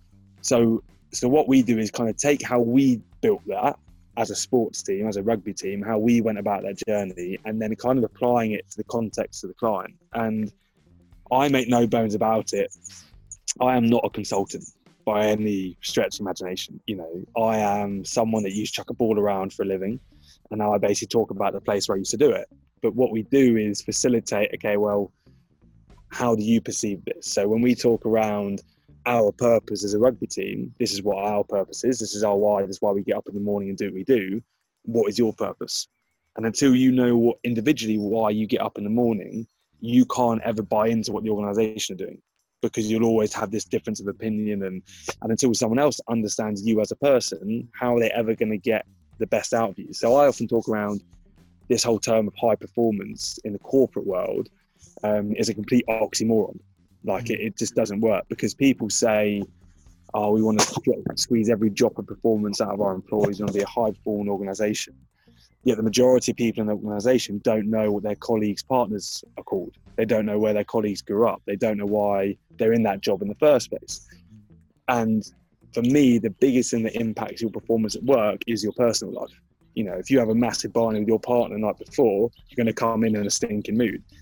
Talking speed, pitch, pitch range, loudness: 225 wpm, 110 Hz, 100-115 Hz, -23 LUFS